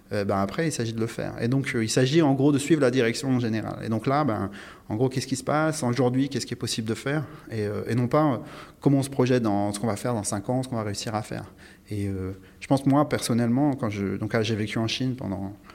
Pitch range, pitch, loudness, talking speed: 105-135 Hz, 120 Hz, -25 LUFS, 290 wpm